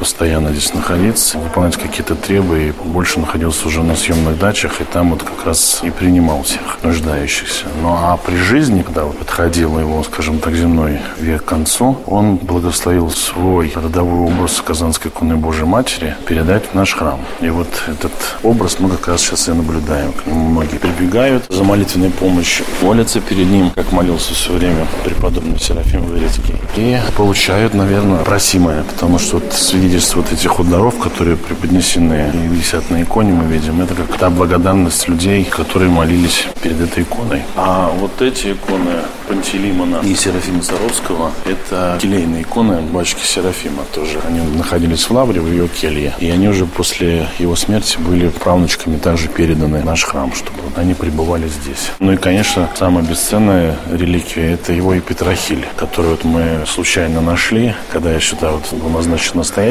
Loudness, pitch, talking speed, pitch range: -14 LUFS, 85 Hz, 165 wpm, 80-95 Hz